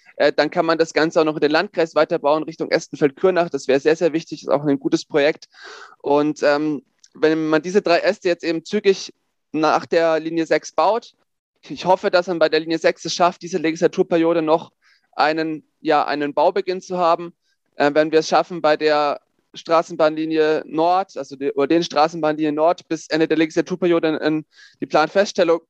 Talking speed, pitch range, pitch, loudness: 190 wpm, 155-175 Hz, 160 Hz, -19 LUFS